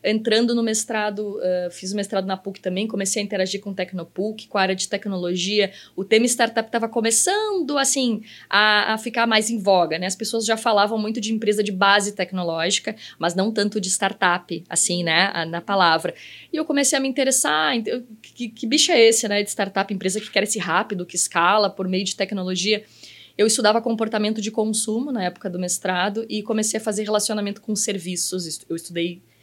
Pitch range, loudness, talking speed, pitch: 190-225 Hz, -21 LUFS, 200 wpm, 210 Hz